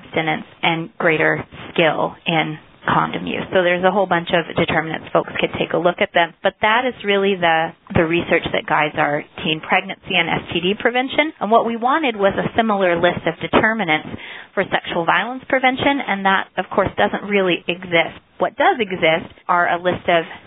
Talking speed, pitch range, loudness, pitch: 185 wpm, 170-210 Hz, -18 LUFS, 185 Hz